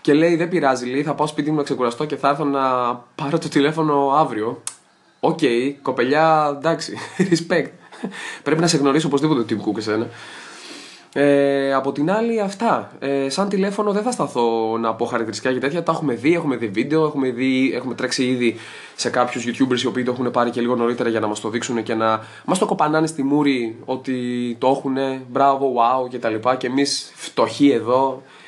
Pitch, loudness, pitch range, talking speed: 135 Hz, -20 LUFS, 120-150 Hz, 195 wpm